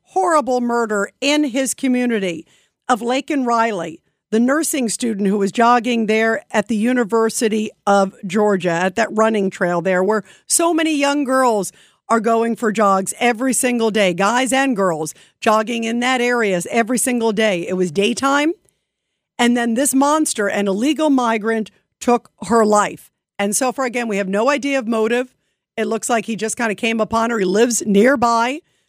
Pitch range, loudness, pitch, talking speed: 205-250 Hz, -17 LUFS, 230 Hz, 175 wpm